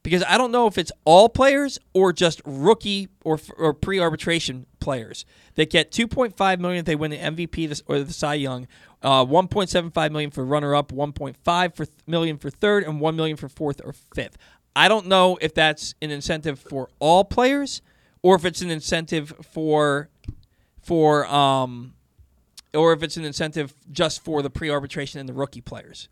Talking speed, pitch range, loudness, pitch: 175 wpm, 145-180 Hz, -21 LUFS, 155 Hz